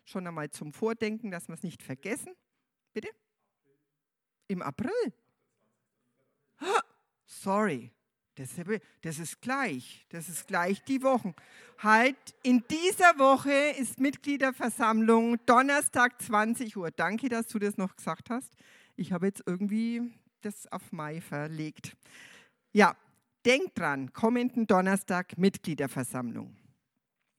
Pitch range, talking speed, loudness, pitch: 170-250 Hz, 115 wpm, -29 LUFS, 215 Hz